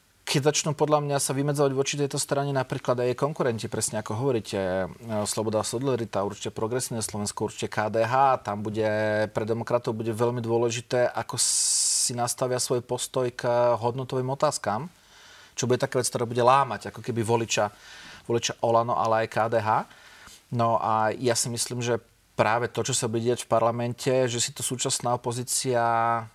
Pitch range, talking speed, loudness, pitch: 115-130 Hz, 165 wpm, -26 LUFS, 120 Hz